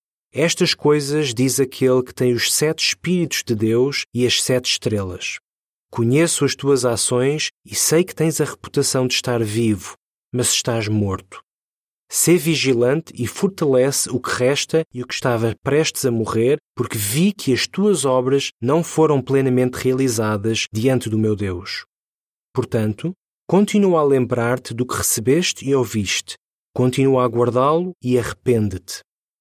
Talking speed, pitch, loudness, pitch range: 150 wpm, 130 Hz, -19 LUFS, 115-150 Hz